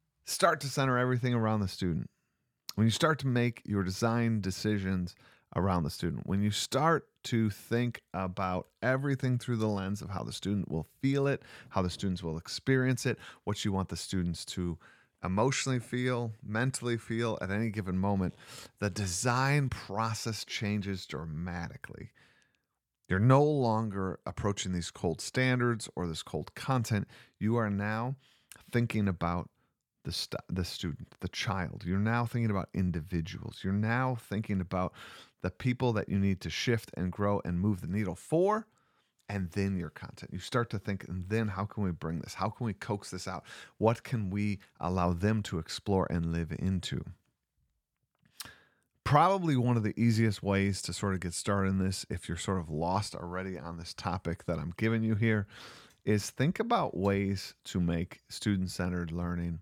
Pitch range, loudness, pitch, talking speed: 90-115 Hz, -32 LUFS, 100 Hz, 170 wpm